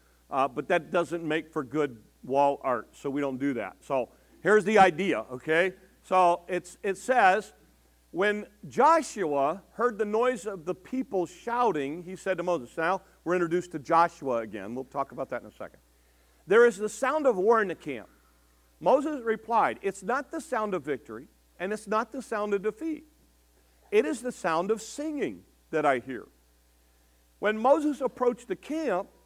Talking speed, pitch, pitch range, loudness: 180 wpm, 185 Hz, 140-225 Hz, -28 LUFS